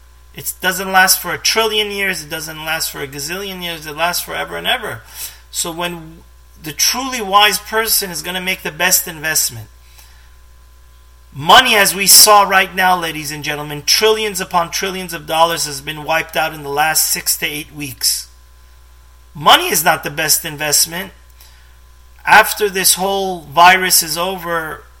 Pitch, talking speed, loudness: 160 Hz, 165 wpm, -13 LUFS